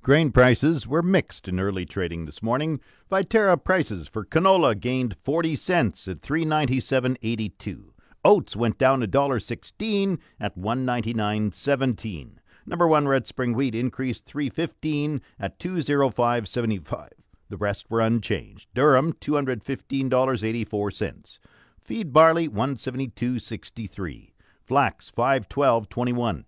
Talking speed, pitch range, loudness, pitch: 145 wpm, 110-145 Hz, -24 LUFS, 125 Hz